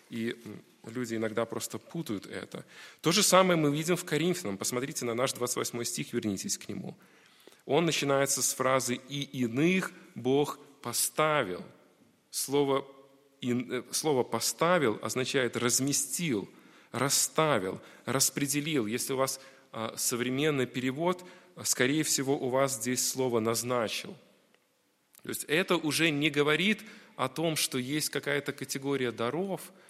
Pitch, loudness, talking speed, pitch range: 135 Hz, -29 LUFS, 120 wpm, 125-155 Hz